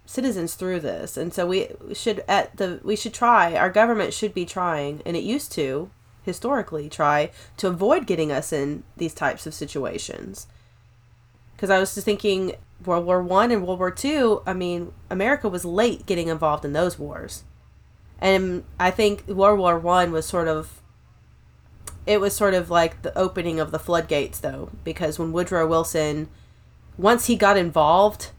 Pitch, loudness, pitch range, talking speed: 180 Hz, -22 LUFS, 160-205 Hz, 175 wpm